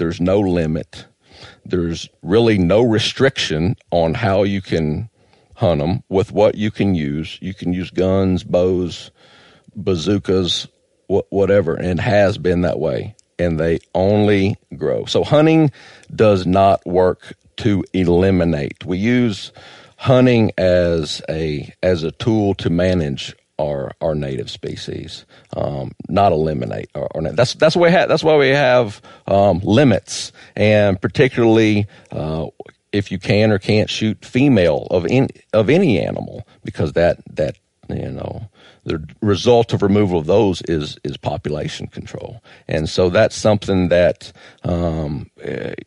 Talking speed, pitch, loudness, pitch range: 140 wpm, 95 Hz, -17 LUFS, 85-110 Hz